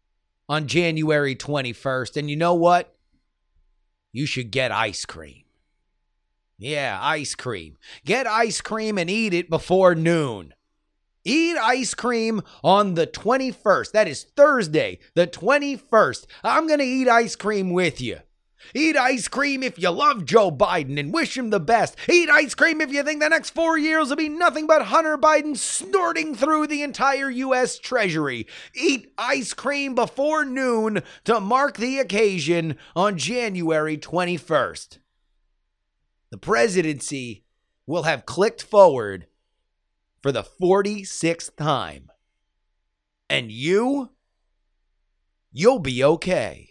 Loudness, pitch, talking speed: -21 LUFS, 185 Hz, 135 wpm